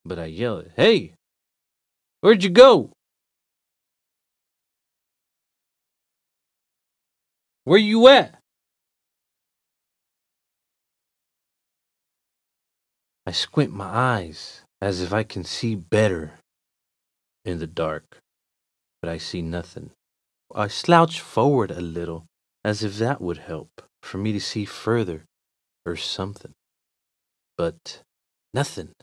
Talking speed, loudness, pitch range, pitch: 95 wpm, -20 LUFS, 80-115 Hz, 95 Hz